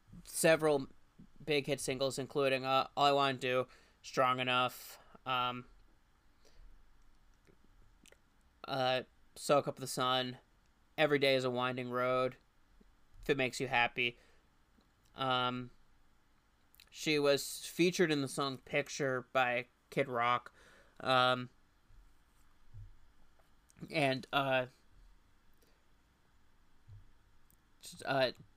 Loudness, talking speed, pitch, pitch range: -34 LUFS, 95 wpm, 130 Hz, 120-140 Hz